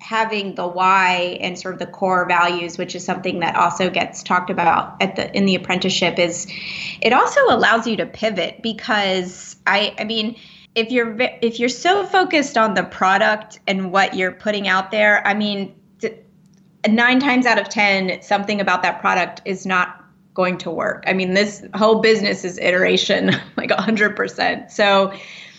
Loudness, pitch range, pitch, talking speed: -18 LUFS, 180-220 Hz, 195 Hz, 180 wpm